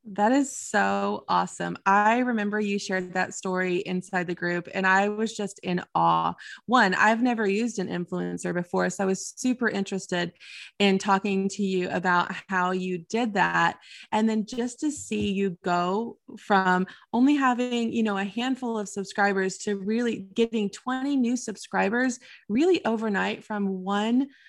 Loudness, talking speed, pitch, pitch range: -26 LUFS, 160 wpm, 200 Hz, 185-230 Hz